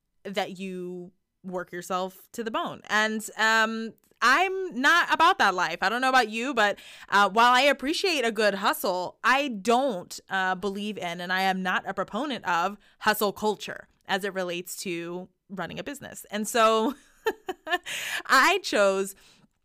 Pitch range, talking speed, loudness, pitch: 190-260 Hz, 160 wpm, -25 LUFS, 210 Hz